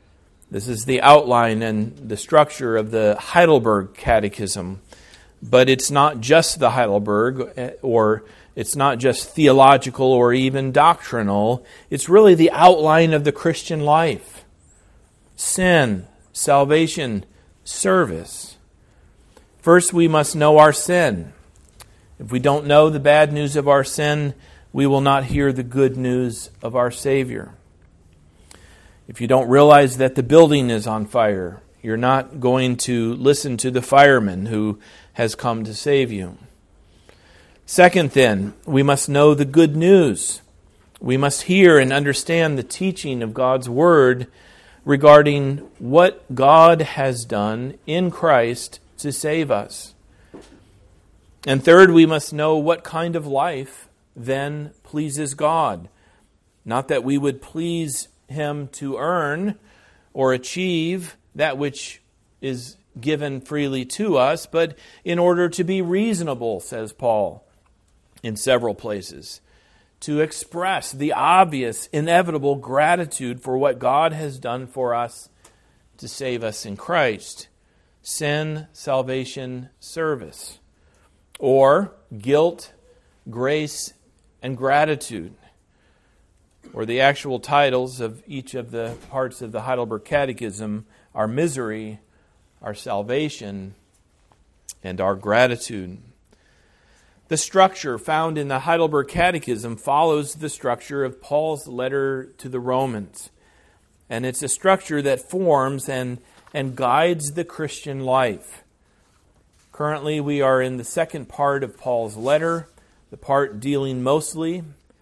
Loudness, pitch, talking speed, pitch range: -18 LUFS, 130 Hz, 125 wpm, 110-150 Hz